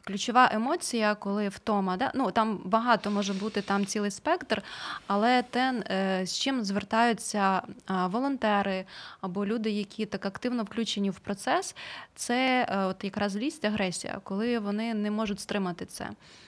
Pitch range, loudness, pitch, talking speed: 200-235 Hz, -29 LUFS, 210 Hz, 140 wpm